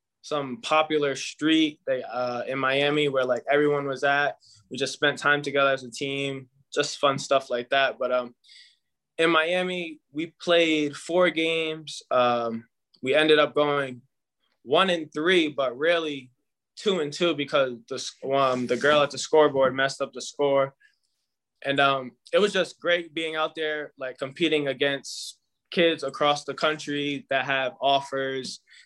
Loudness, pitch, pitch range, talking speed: -25 LUFS, 140 Hz, 135-155 Hz, 160 wpm